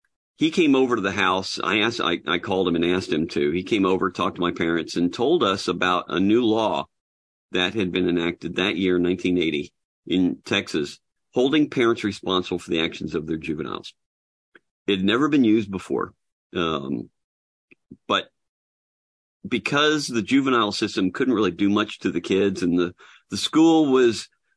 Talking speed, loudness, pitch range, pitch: 175 wpm, -22 LUFS, 85-110 Hz, 95 Hz